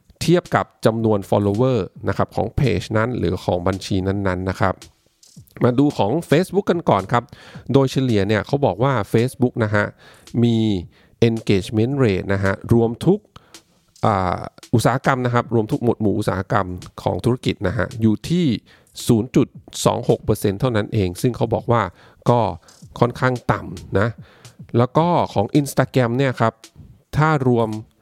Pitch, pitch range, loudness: 115 Hz, 100-130 Hz, -20 LUFS